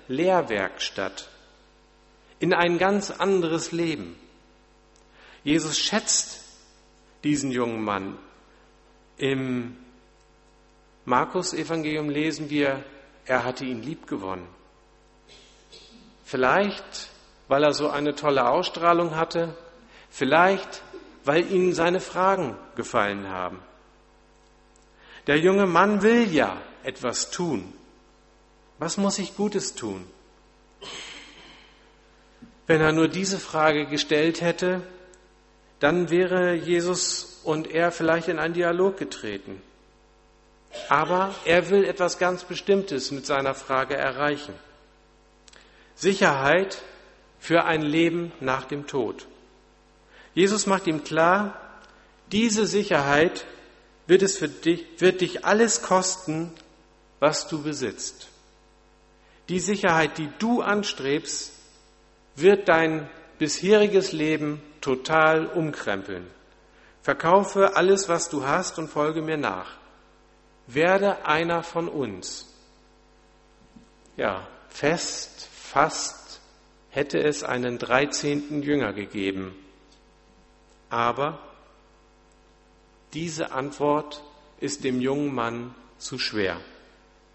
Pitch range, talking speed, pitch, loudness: 125-180 Hz, 95 wpm, 155 Hz, -24 LUFS